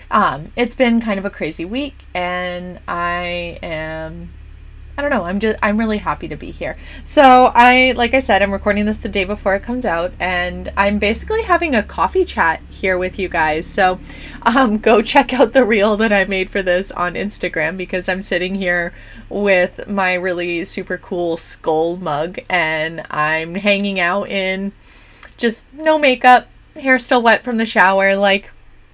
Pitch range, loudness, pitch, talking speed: 175-230 Hz, -16 LUFS, 195 Hz, 180 wpm